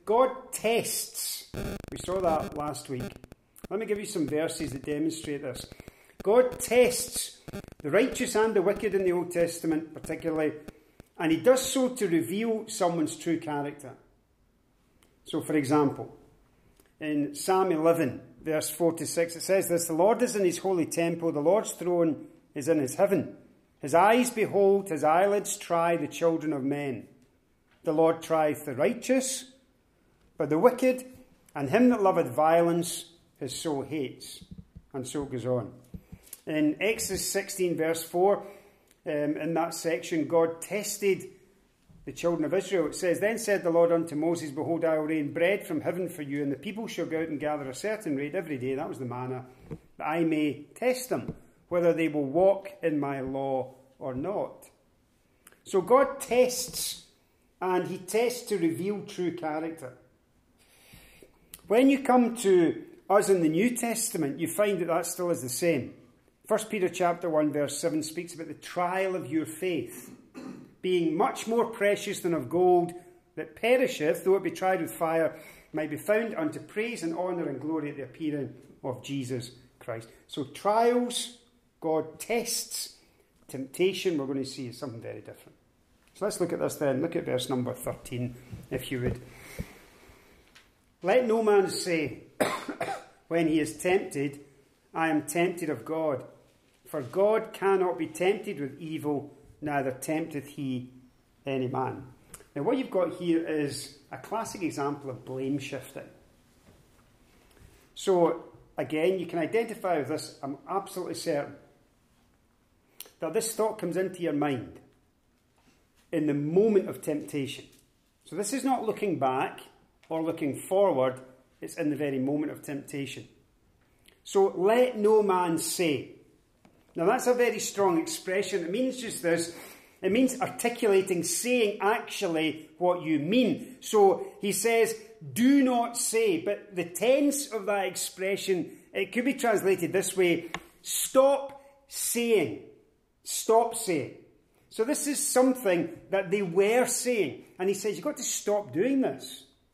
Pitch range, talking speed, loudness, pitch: 150-210 Hz, 155 wpm, -28 LUFS, 170 Hz